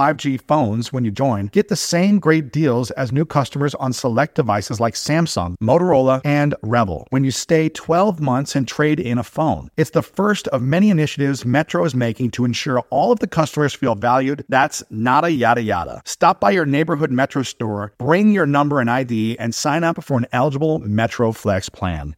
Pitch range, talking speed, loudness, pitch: 120-155 Hz, 200 wpm, -18 LUFS, 135 Hz